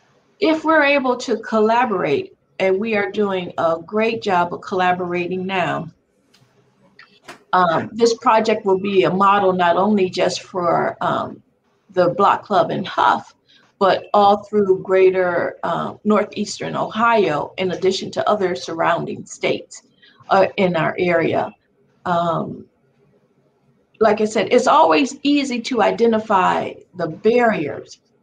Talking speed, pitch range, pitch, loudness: 130 wpm, 185-220 Hz, 200 Hz, -18 LUFS